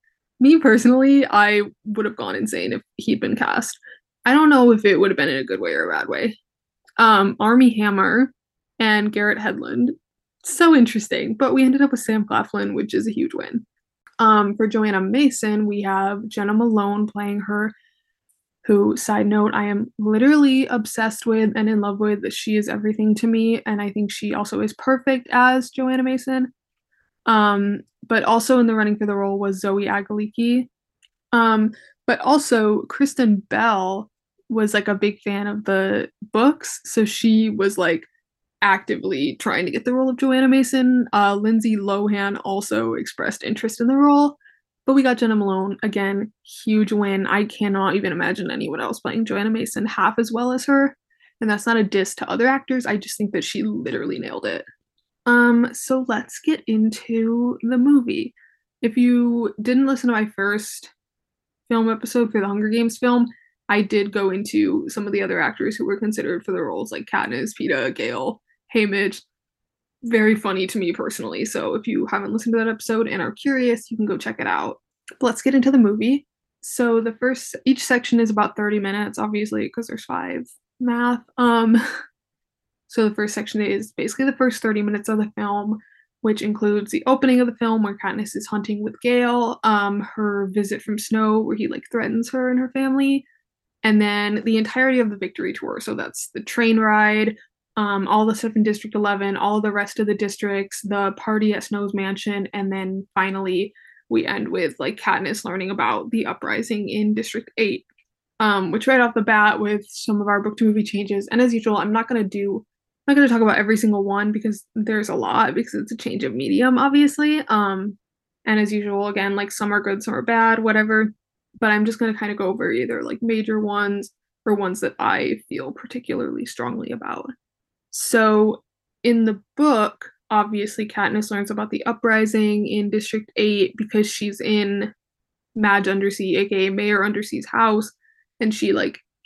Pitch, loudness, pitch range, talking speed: 220 Hz, -20 LUFS, 205-245 Hz, 185 wpm